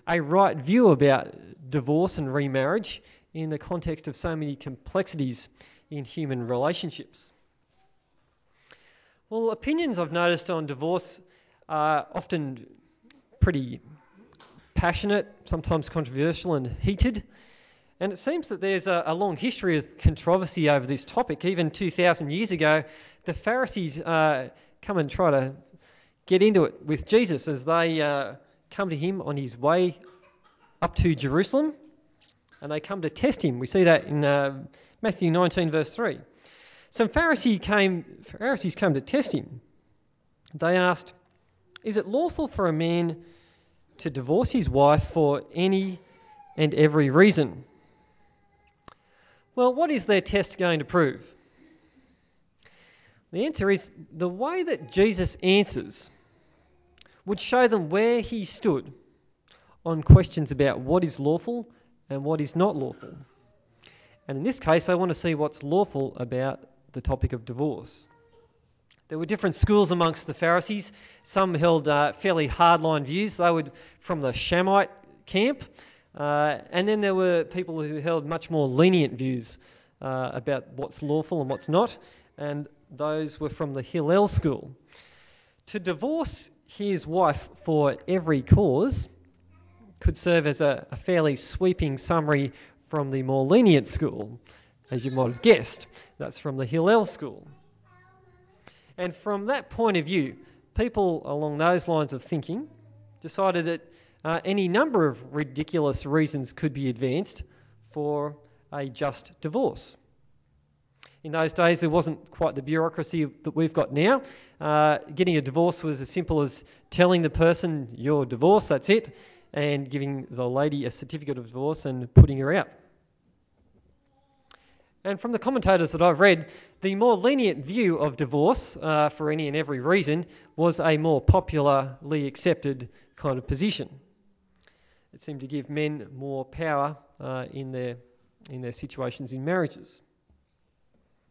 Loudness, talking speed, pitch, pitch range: -25 LUFS, 145 wpm, 160 Hz, 140-180 Hz